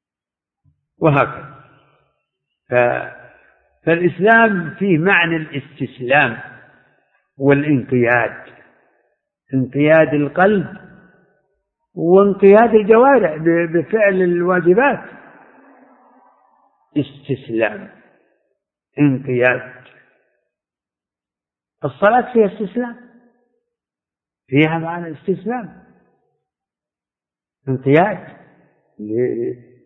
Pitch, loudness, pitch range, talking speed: 170 Hz, -16 LUFS, 135-200 Hz, 40 wpm